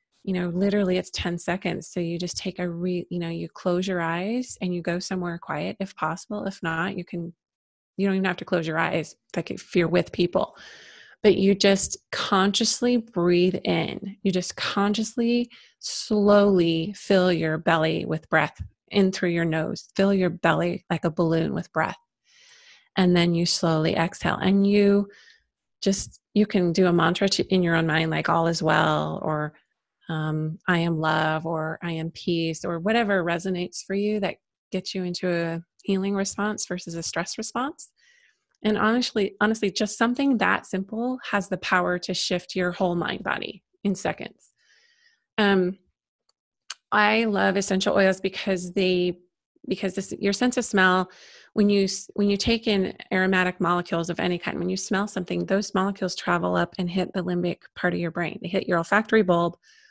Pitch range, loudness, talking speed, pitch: 175-205 Hz, -24 LUFS, 180 wpm, 185 Hz